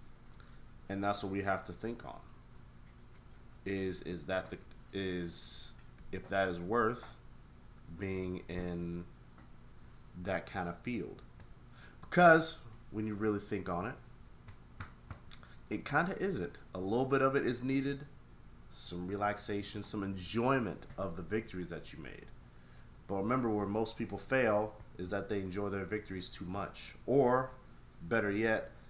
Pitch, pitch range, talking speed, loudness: 100 Hz, 90-110 Hz, 140 wpm, -36 LUFS